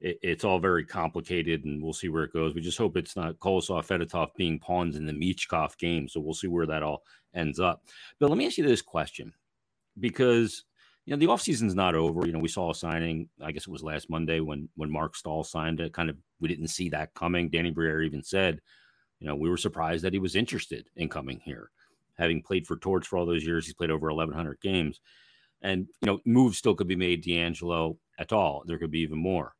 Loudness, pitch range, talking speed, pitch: -29 LUFS, 80-90 Hz, 235 wpm, 85 Hz